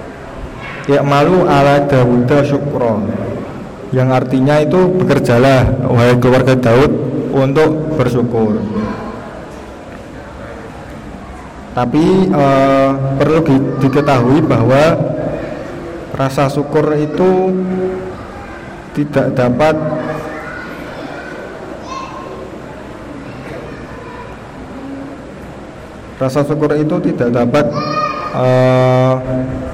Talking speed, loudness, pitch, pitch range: 60 wpm, -13 LUFS, 135 Hz, 125-150 Hz